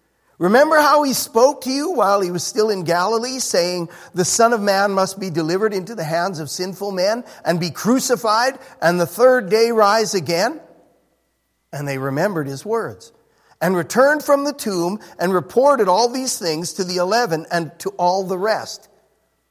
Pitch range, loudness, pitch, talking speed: 175-235 Hz, -18 LUFS, 200 Hz, 180 wpm